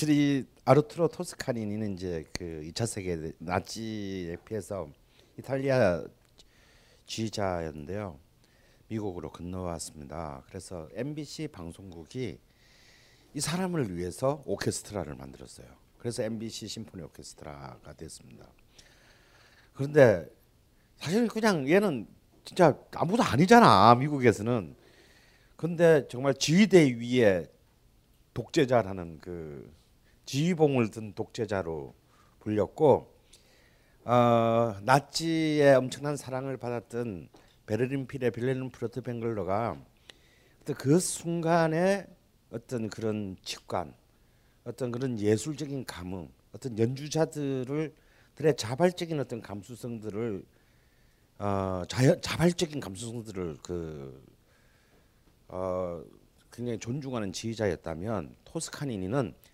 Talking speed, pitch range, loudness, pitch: 245 characters per minute, 95-140 Hz, -29 LUFS, 115 Hz